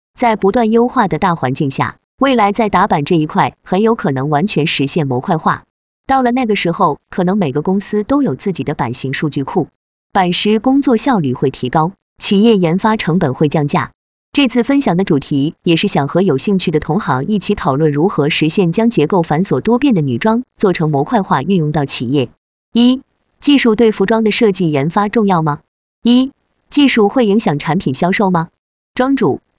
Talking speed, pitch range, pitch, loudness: 285 characters per minute, 150-225 Hz, 190 Hz, -14 LUFS